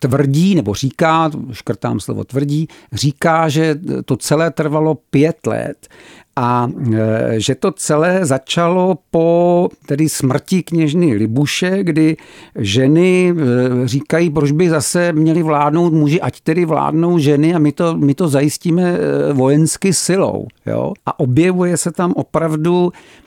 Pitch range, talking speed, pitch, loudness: 140-170 Hz, 130 wpm, 155 Hz, -15 LUFS